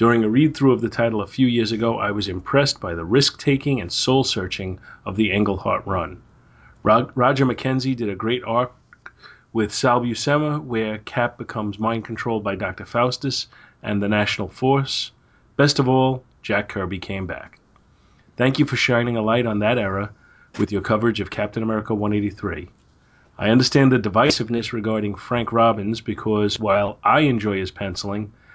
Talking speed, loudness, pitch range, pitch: 165 wpm, -21 LUFS, 105-125 Hz, 115 Hz